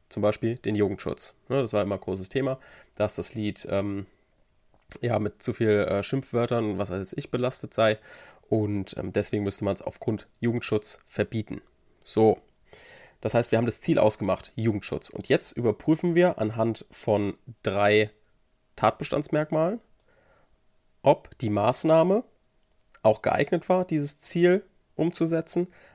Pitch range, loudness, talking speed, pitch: 105-145 Hz, -26 LUFS, 135 wpm, 110 Hz